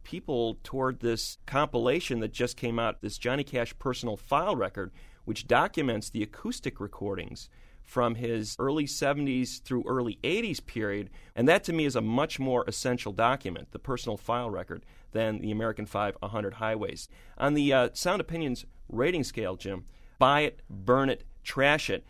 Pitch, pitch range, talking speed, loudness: 120 Hz, 110-135 Hz, 165 wpm, -30 LUFS